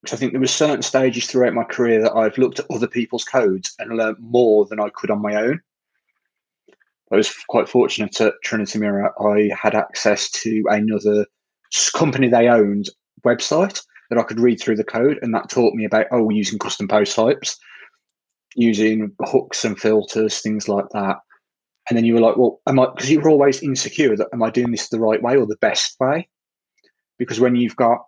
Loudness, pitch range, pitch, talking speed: -18 LUFS, 110-125 Hz, 115 Hz, 200 wpm